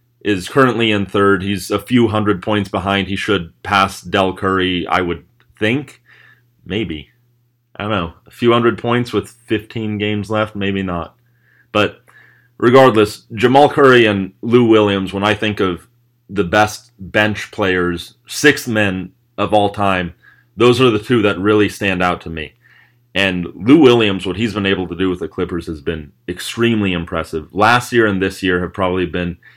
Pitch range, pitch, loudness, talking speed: 95-115 Hz, 105 Hz, -15 LUFS, 175 wpm